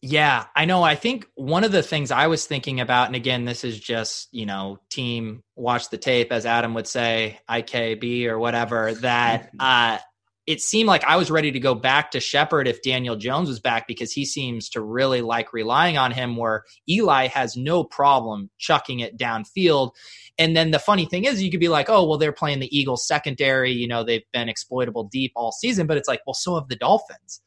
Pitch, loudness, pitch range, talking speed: 125 Hz, -21 LUFS, 115-150 Hz, 215 wpm